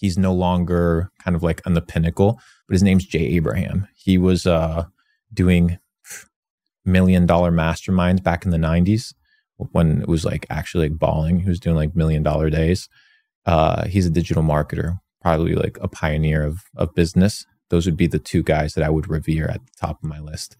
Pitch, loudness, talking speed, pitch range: 85 Hz, -20 LUFS, 195 wpm, 80-95 Hz